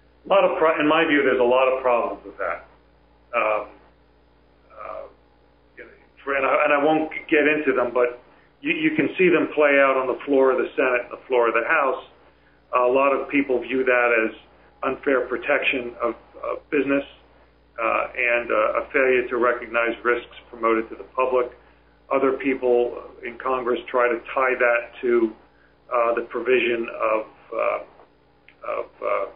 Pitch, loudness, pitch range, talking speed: 125 Hz, -22 LUFS, 105-135 Hz, 170 wpm